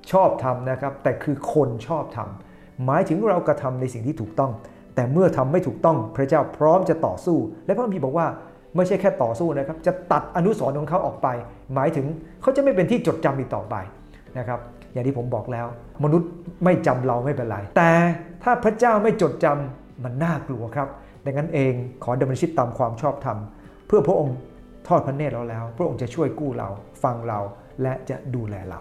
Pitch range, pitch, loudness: 120-165 Hz, 135 Hz, -23 LUFS